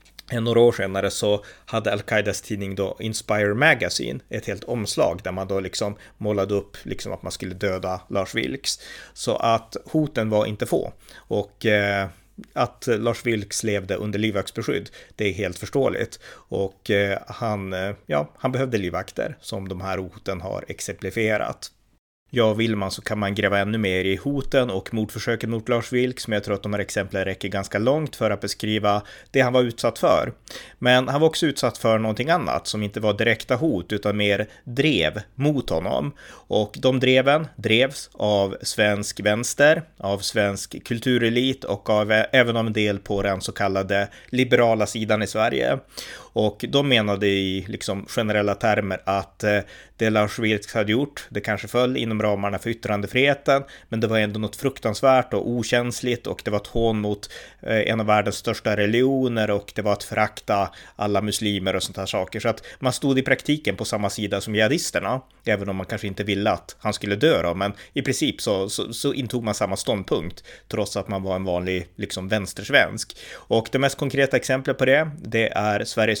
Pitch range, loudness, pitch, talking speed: 100-120 Hz, -23 LUFS, 105 Hz, 185 wpm